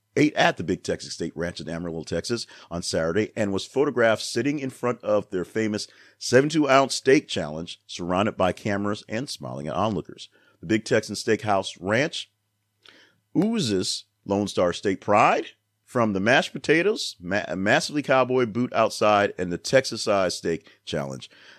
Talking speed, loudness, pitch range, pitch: 155 wpm, -24 LUFS, 95-115 Hz, 105 Hz